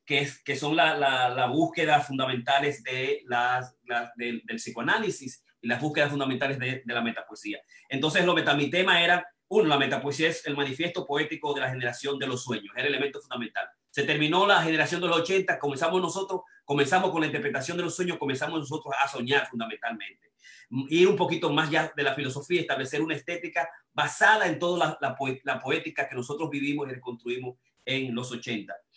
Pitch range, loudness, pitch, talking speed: 130-170 Hz, -27 LUFS, 145 Hz, 190 wpm